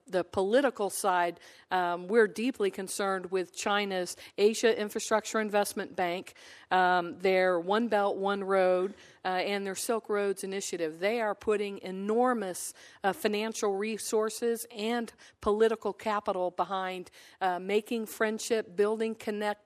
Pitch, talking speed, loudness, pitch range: 205 Hz, 125 wpm, -30 LUFS, 185-220 Hz